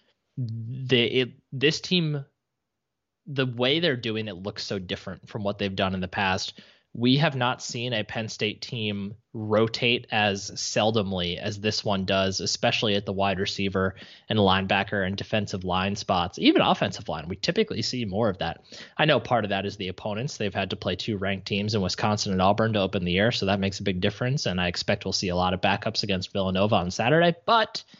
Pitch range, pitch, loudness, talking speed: 100-120 Hz, 105 Hz, -25 LUFS, 210 wpm